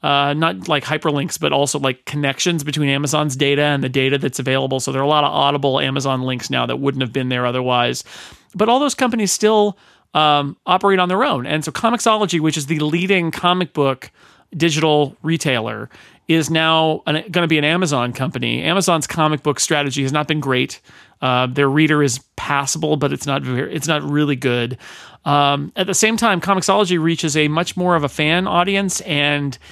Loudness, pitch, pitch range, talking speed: -17 LUFS, 150 Hz, 140-170 Hz, 195 wpm